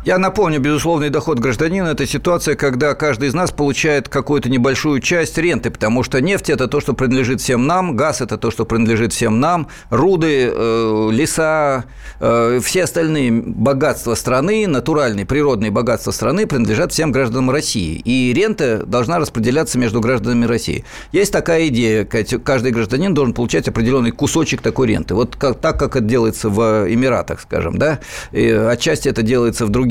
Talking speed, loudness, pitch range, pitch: 160 wpm, -16 LUFS, 115-150 Hz, 130 Hz